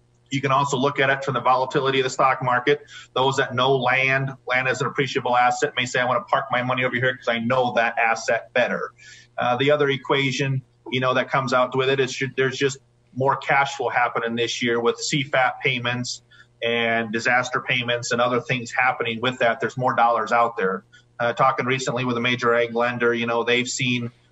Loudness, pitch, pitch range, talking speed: -21 LUFS, 125 Hz, 120-135 Hz, 215 wpm